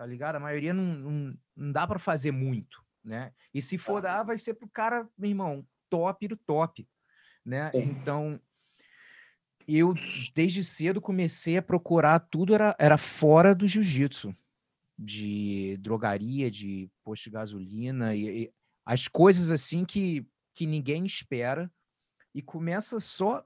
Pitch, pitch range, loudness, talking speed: 155 Hz, 125-185 Hz, -28 LUFS, 150 wpm